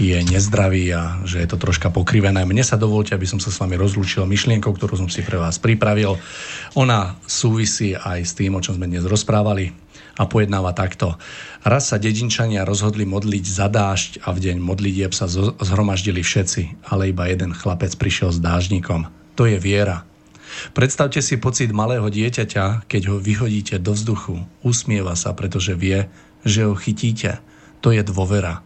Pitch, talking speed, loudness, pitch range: 100 Hz, 170 wpm, -19 LUFS, 95-110 Hz